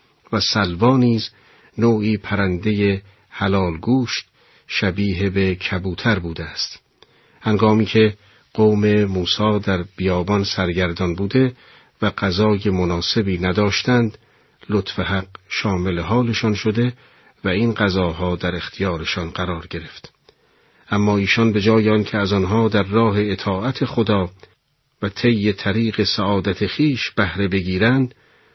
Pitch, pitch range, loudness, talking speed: 100 Hz, 95-110 Hz, -19 LUFS, 110 wpm